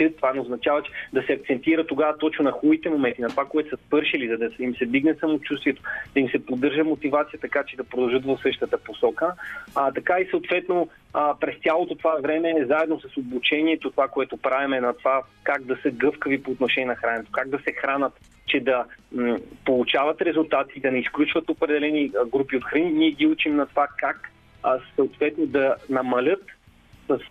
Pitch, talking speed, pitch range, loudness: 145 Hz, 195 wpm, 130-160 Hz, -24 LUFS